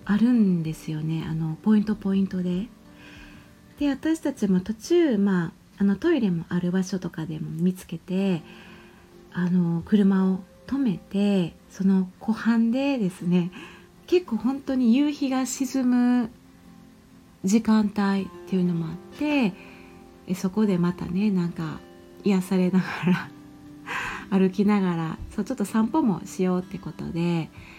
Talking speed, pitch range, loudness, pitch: 260 characters per minute, 175-220 Hz, -25 LUFS, 190 Hz